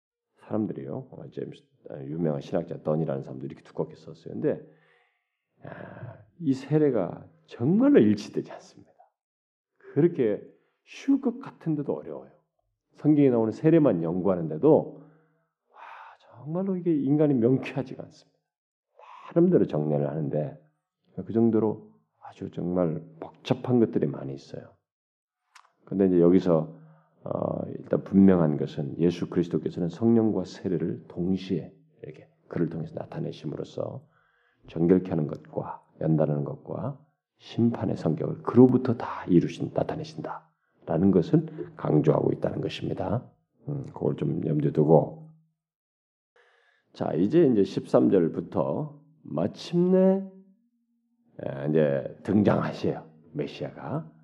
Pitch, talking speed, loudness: 115 Hz, 275 characters per minute, -26 LUFS